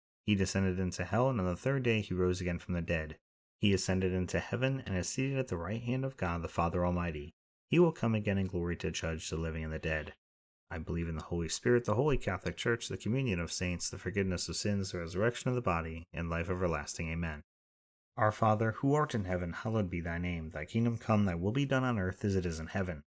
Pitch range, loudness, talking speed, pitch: 85-110 Hz, -34 LUFS, 245 wpm, 90 Hz